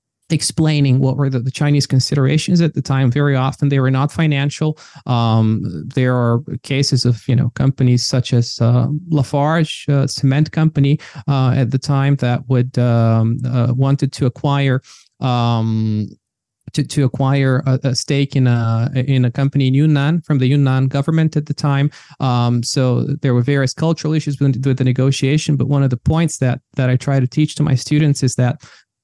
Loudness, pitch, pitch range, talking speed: -16 LUFS, 135 Hz, 125-145 Hz, 185 wpm